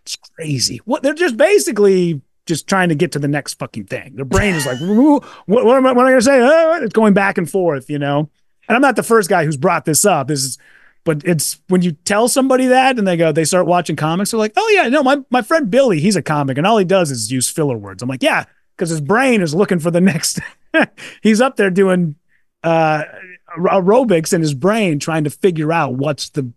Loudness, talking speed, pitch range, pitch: -15 LUFS, 235 wpm, 155-220 Hz, 180 Hz